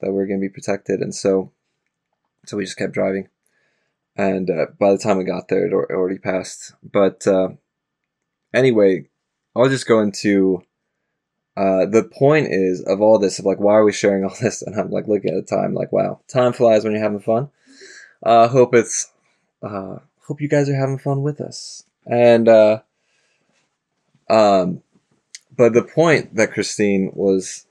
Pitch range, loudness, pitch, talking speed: 95-120 Hz, -18 LUFS, 105 Hz, 185 wpm